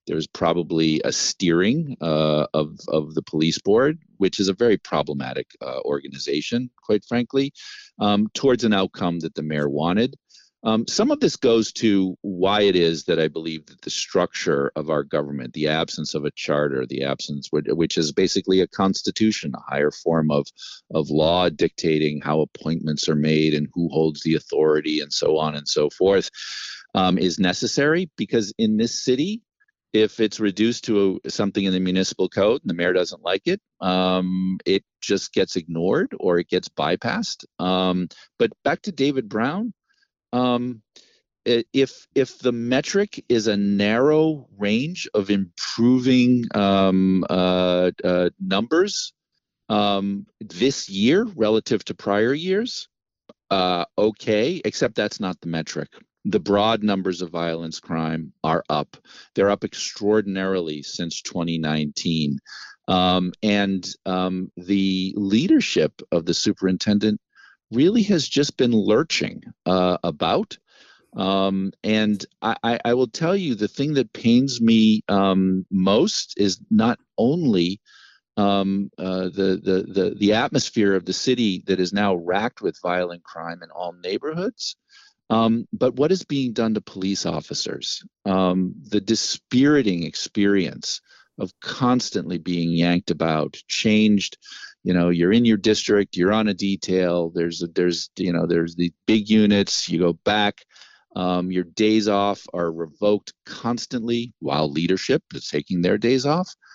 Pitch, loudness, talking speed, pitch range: 95 Hz, -22 LUFS, 150 wpm, 85-115 Hz